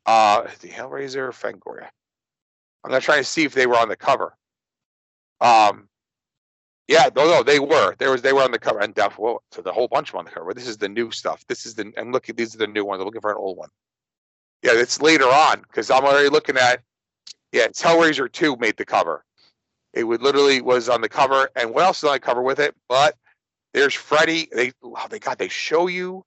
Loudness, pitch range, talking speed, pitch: -19 LUFS, 120-150 Hz, 240 wpm, 130 Hz